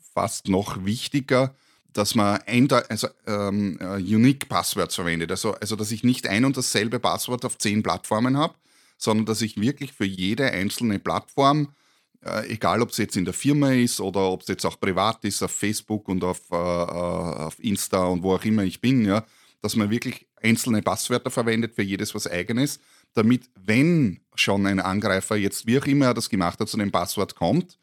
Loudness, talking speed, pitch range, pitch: -24 LUFS, 190 wpm, 95-125 Hz, 110 Hz